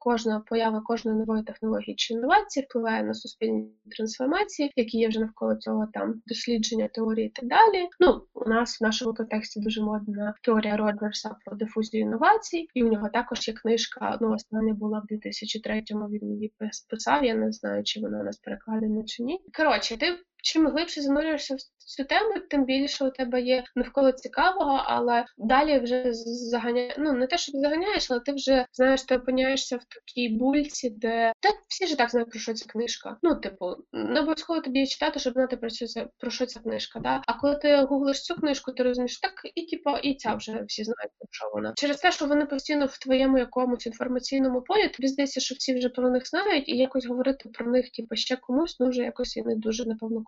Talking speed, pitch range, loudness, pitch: 205 wpm, 220-275 Hz, -27 LUFS, 245 Hz